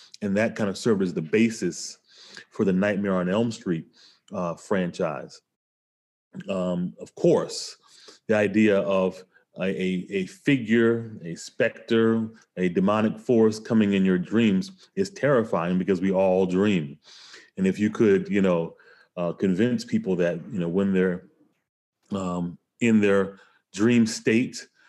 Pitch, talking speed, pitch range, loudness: 100 Hz, 140 wpm, 95-115 Hz, -24 LUFS